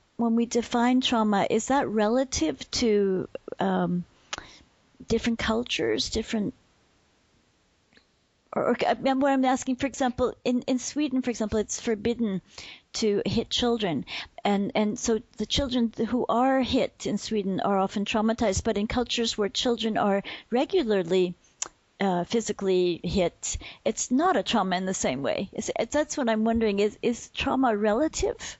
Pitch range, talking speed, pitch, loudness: 205-250 Hz, 145 wpm, 225 Hz, -26 LUFS